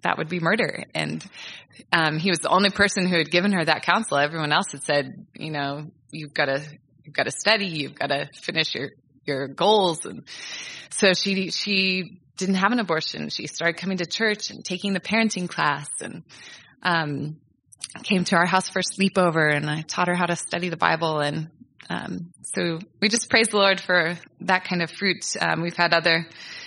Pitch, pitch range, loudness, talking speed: 175 Hz, 155-195 Hz, -23 LUFS, 195 wpm